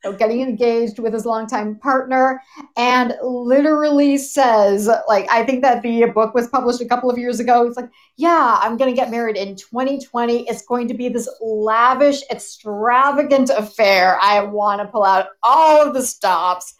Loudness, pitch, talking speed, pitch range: -16 LUFS, 240 Hz, 175 wpm, 220-260 Hz